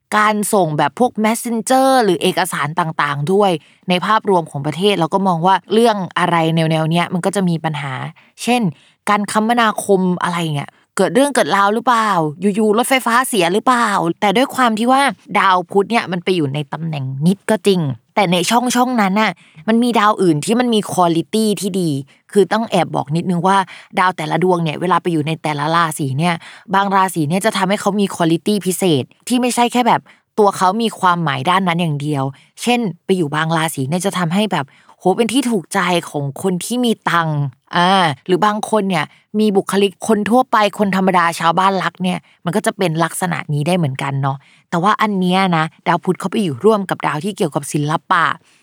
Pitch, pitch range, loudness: 185 Hz, 165-215 Hz, -16 LUFS